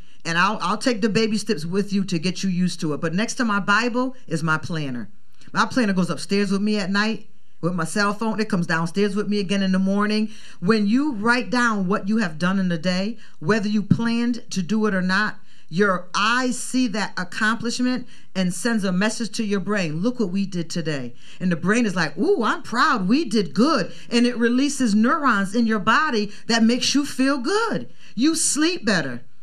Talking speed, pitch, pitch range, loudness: 215 wpm, 210 Hz, 185-235 Hz, -22 LUFS